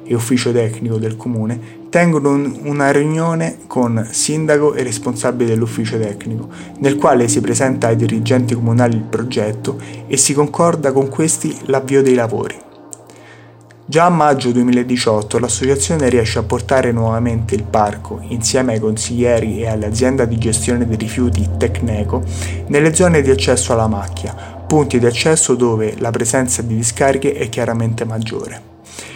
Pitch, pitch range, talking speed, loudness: 120 Hz, 110-135 Hz, 140 wpm, -15 LUFS